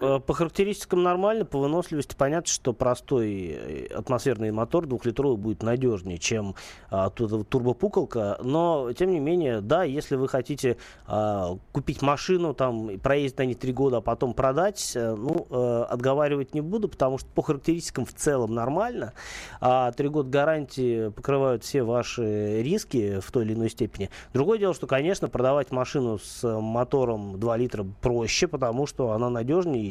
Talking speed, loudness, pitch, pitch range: 155 wpm, -26 LUFS, 130 Hz, 115-150 Hz